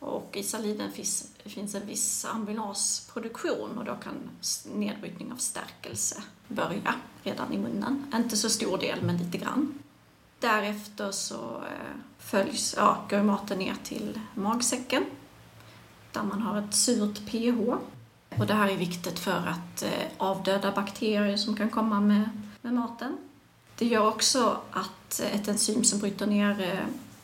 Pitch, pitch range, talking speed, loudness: 210 Hz, 200-230 Hz, 145 wpm, -29 LUFS